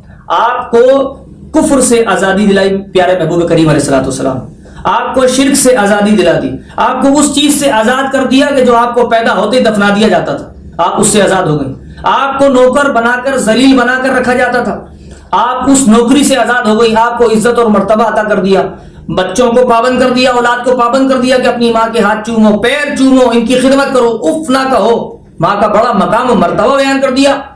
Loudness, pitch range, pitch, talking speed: -8 LUFS, 215-265 Hz, 240 Hz, 220 wpm